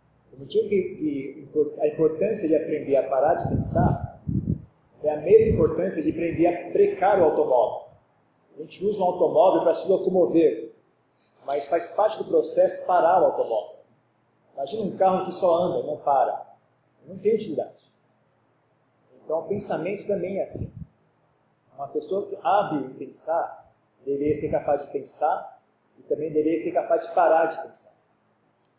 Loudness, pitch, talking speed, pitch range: -24 LUFS, 180 Hz, 150 wpm, 160-220 Hz